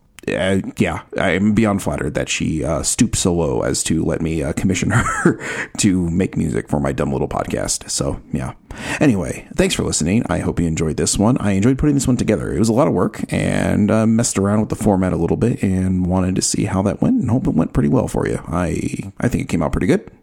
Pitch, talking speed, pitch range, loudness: 95 Hz, 250 wpm, 85-110 Hz, -18 LUFS